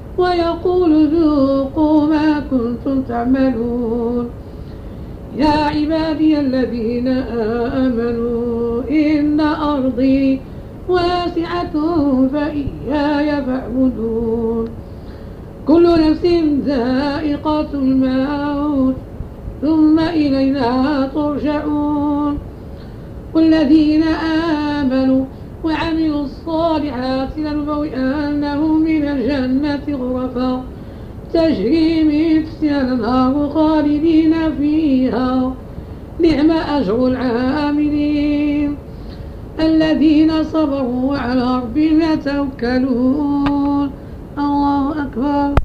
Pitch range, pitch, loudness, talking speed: 260-310 Hz, 290 Hz, -16 LUFS, 60 wpm